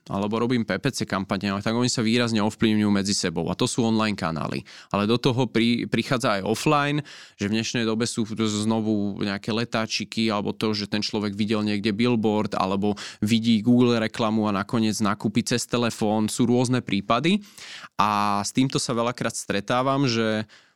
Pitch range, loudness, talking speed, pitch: 105-120 Hz, -24 LUFS, 165 wpm, 110 Hz